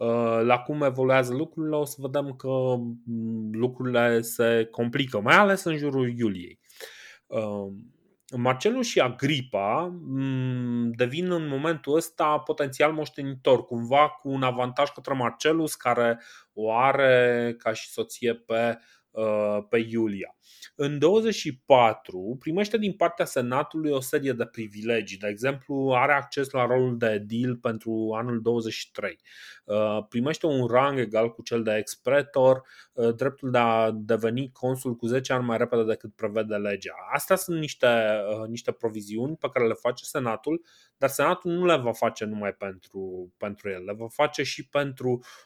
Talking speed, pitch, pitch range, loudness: 140 wpm, 125 Hz, 115-145 Hz, -26 LUFS